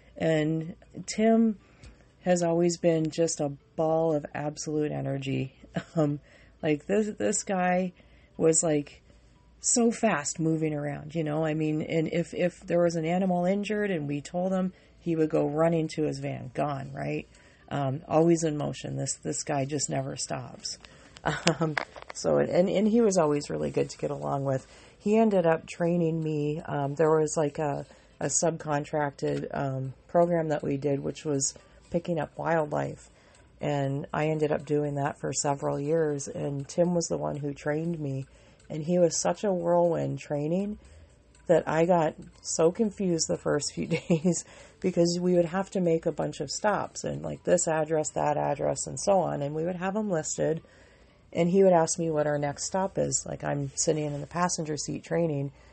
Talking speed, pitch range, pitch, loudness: 180 wpm, 145-175 Hz, 155 Hz, -28 LUFS